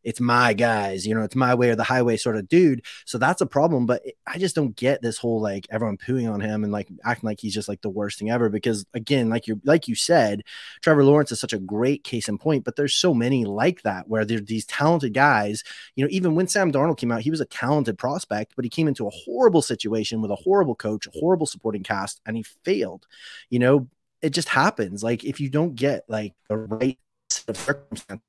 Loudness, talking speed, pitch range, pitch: -23 LUFS, 245 wpm, 110-145 Hz, 120 Hz